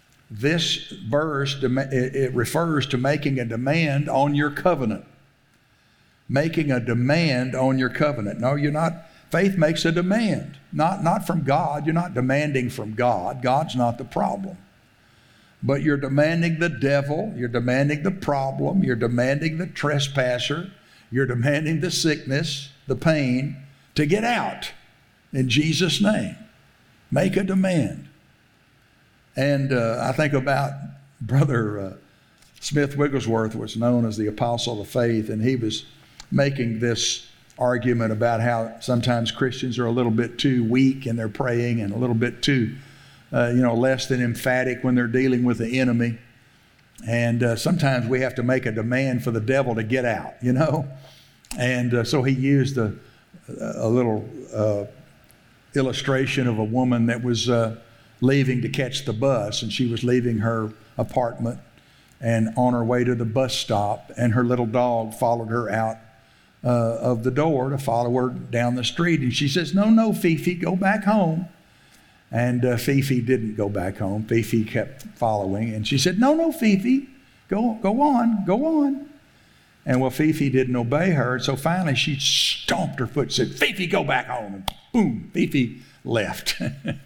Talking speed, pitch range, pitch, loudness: 165 wpm, 120-150 Hz, 130 Hz, -22 LUFS